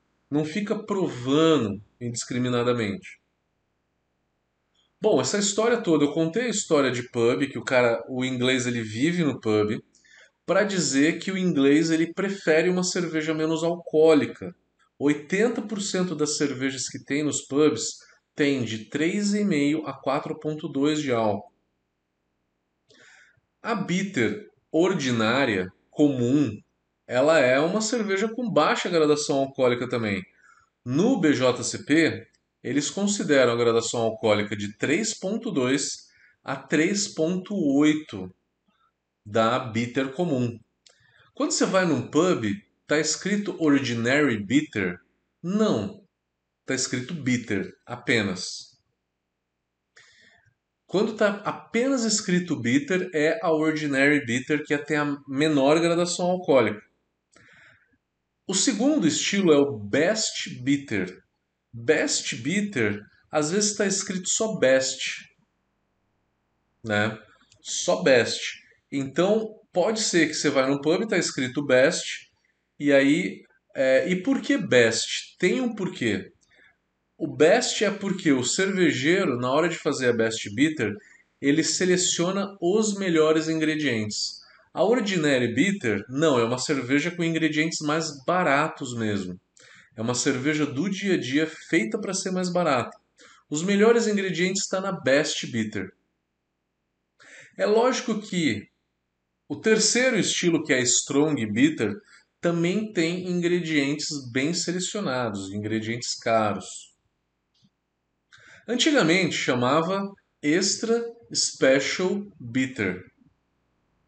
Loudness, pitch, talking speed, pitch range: -24 LUFS, 150 Hz, 115 wpm, 125-185 Hz